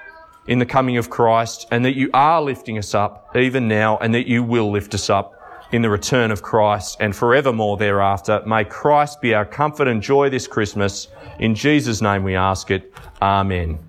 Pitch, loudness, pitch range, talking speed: 110 Hz, -18 LUFS, 105-130 Hz, 195 wpm